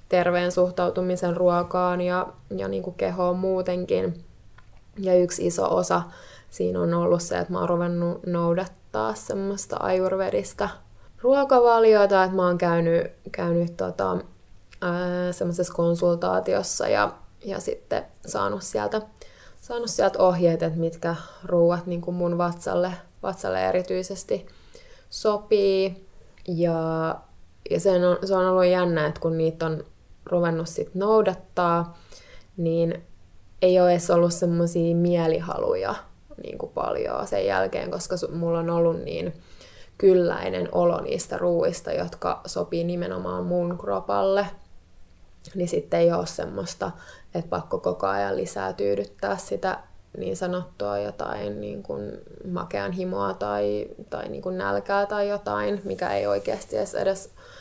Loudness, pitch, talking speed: -25 LUFS, 170 Hz, 125 wpm